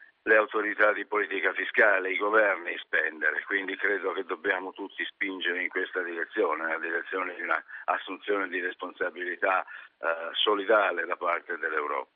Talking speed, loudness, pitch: 145 wpm, -28 LUFS, 360 Hz